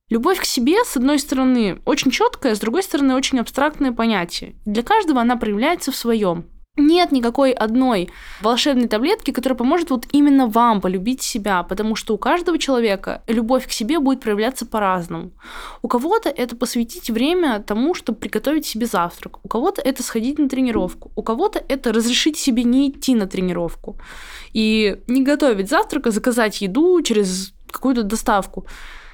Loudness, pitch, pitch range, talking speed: -19 LUFS, 245 Hz, 220-280 Hz, 160 wpm